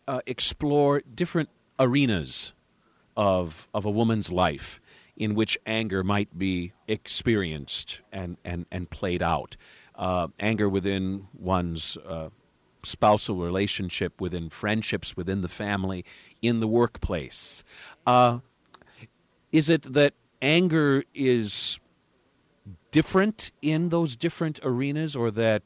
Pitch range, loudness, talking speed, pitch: 90-130 Hz, -26 LUFS, 115 wpm, 105 Hz